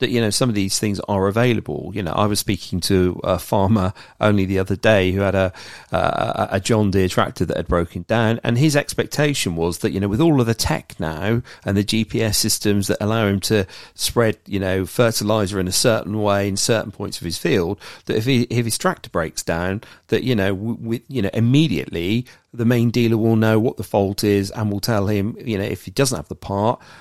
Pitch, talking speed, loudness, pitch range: 105 Hz, 235 wpm, -20 LUFS, 95-115 Hz